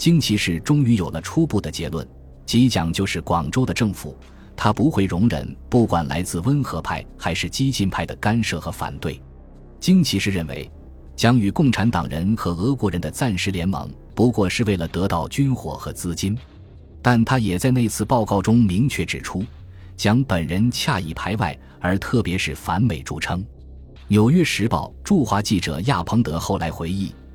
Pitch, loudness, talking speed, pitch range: 95 Hz, -21 LUFS, 260 characters per minute, 80-115 Hz